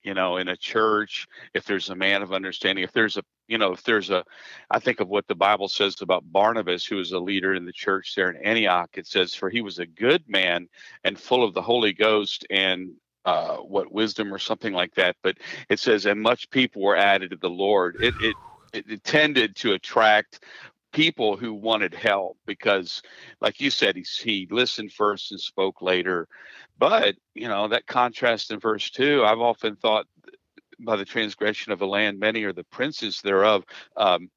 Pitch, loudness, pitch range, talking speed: 100 Hz, -23 LUFS, 95-110 Hz, 200 wpm